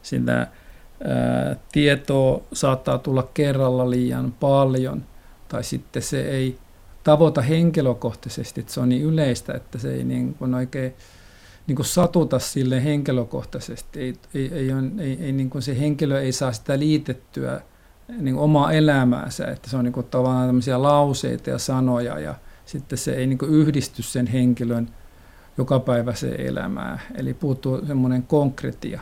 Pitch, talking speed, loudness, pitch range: 130 Hz, 145 wpm, -22 LUFS, 120-140 Hz